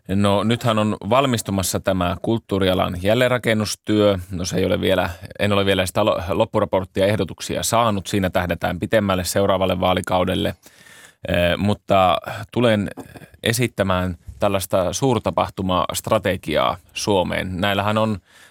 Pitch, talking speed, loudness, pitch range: 100 Hz, 105 wpm, -20 LUFS, 90-105 Hz